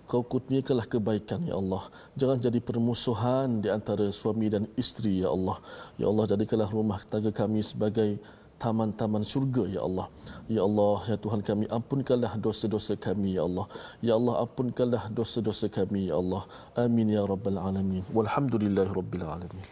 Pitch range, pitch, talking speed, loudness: 100-120 Hz, 110 Hz, 155 wpm, -29 LUFS